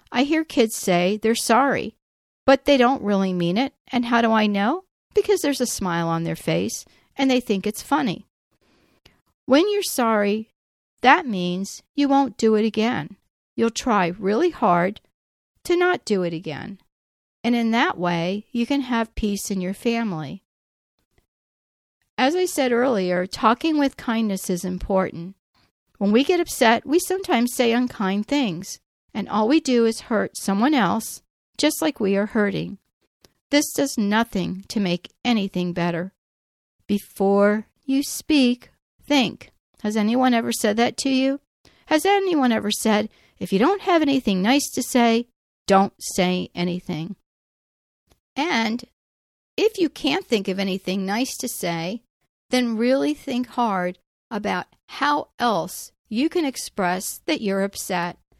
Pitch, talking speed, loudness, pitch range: 225 Hz, 150 wpm, -22 LUFS, 195-265 Hz